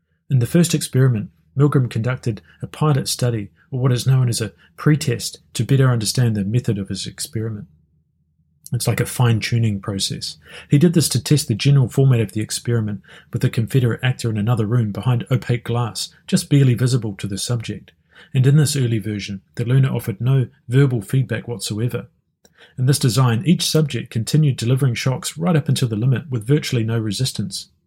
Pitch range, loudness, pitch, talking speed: 110-135 Hz, -19 LUFS, 125 Hz, 185 wpm